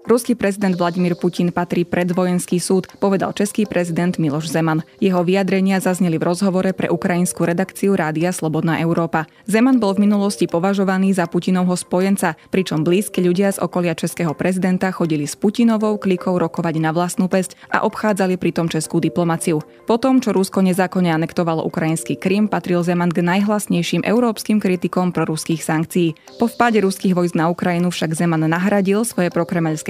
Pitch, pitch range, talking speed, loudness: 180 Hz, 170-195 Hz, 155 wpm, -18 LUFS